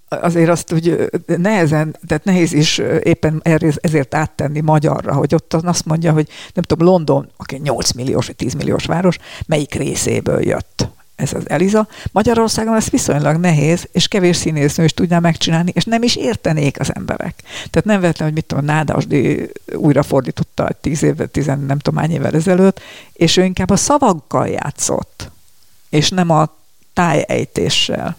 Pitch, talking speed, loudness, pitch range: 160 Hz, 160 wpm, -15 LUFS, 150-175 Hz